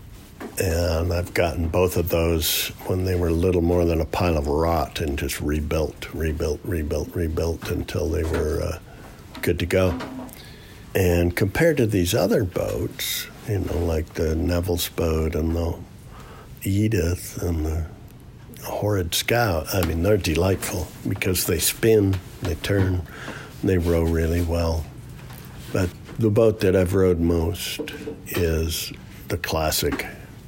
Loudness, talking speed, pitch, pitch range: -23 LUFS, 140 wpm, 85 Hz, 80-95 Hz